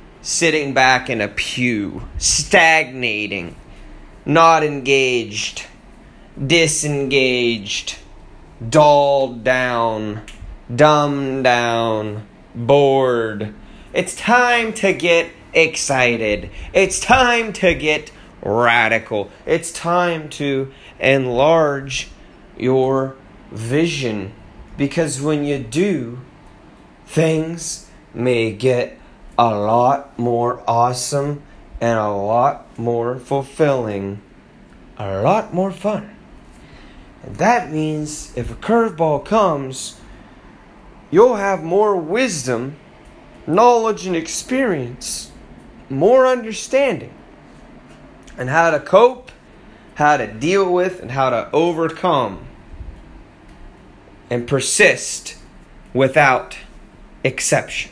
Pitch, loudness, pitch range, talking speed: 140 Hz, -17 LUFS, 120-165 Hz, 85 wpm